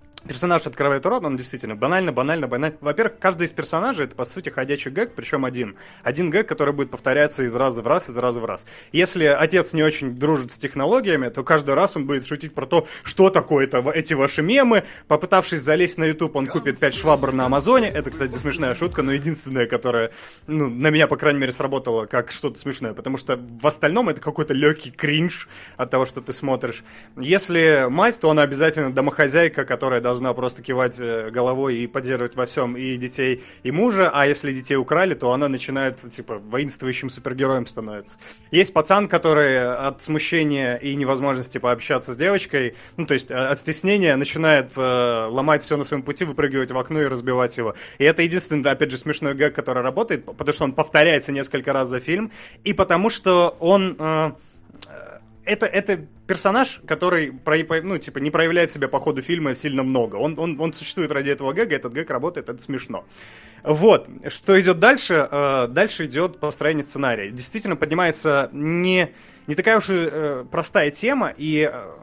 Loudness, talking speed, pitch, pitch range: -20 LUFS, 180 wpm, 145 Hz, 130-165 Hz